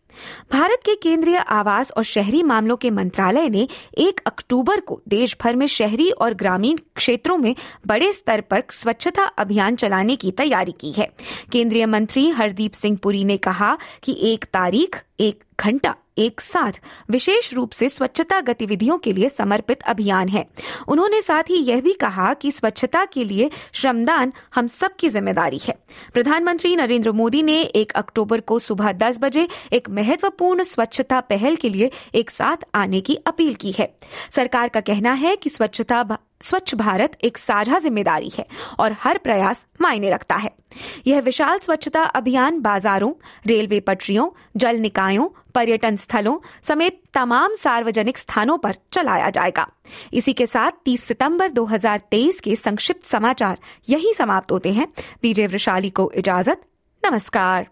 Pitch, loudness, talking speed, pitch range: 240 Hz, -19 LUFS, 155 wpm, 215-305 Hz